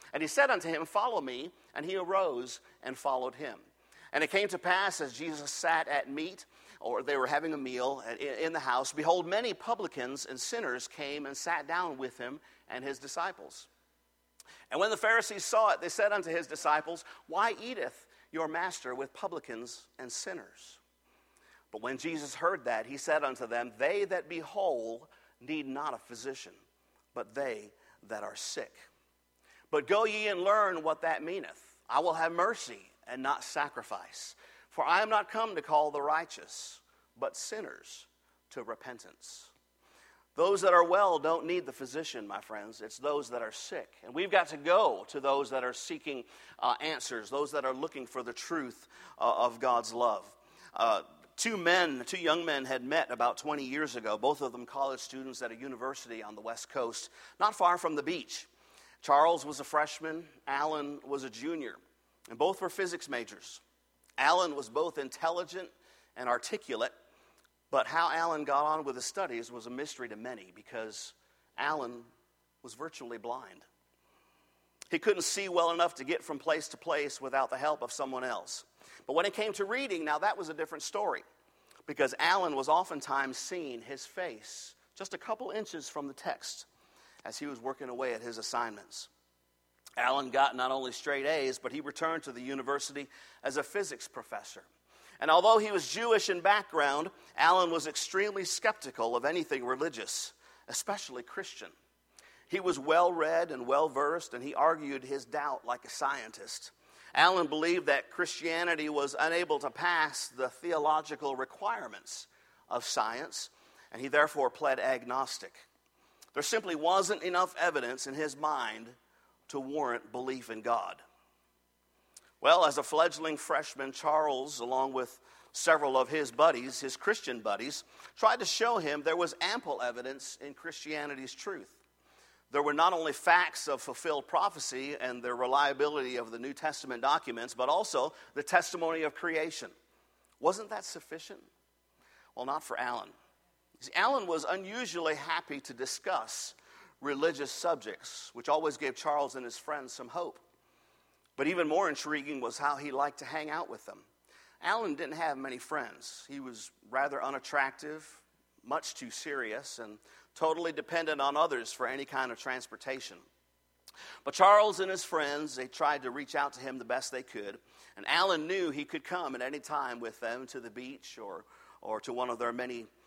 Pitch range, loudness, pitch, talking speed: 130-170 Hz, -33 LUFS, 150 Hz, 170 wpm